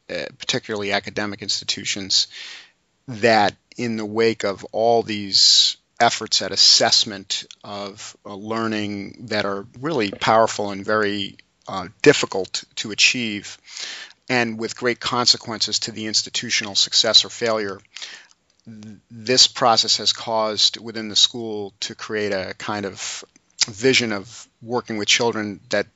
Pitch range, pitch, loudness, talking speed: 100-115 Hz, 110 Hz, -19 LUFS, 125 wpm